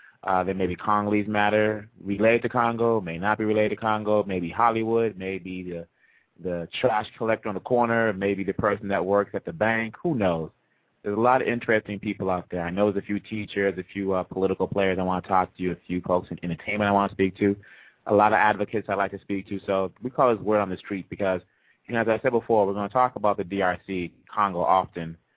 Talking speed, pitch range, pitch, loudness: 245 wpm, 95-110 Hz, 100 Hz, -25 LUFS